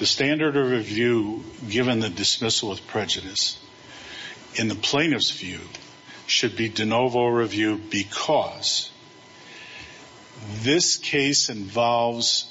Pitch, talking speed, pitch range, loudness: 115 Hz, 105 wpm, 105-125 Hz, -22 LUFS